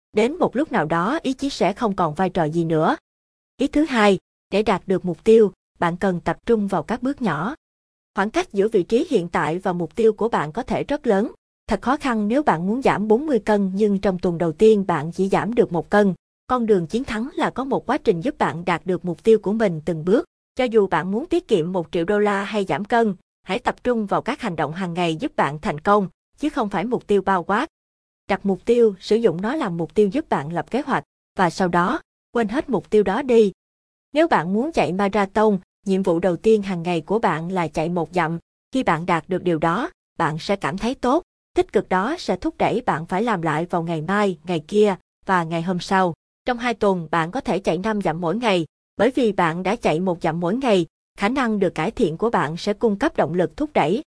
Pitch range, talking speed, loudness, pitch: 175-225 Hz, 245 wpm, -21 LUFS, 200 Hz